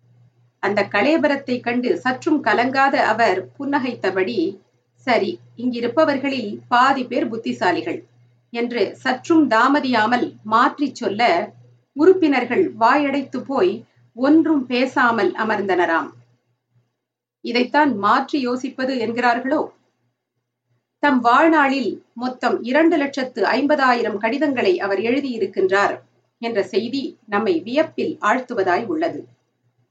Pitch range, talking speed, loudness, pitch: 190-285 Hz, 85 wpm, -19 LUFS, 245 Hz